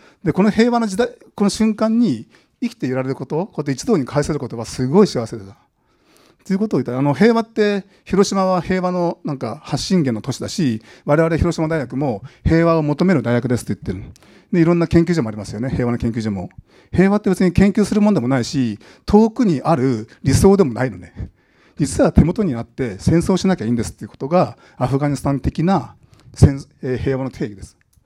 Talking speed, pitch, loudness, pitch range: 410 characters per minute, 155 Hz, -18 LUFS, 125-190 Hz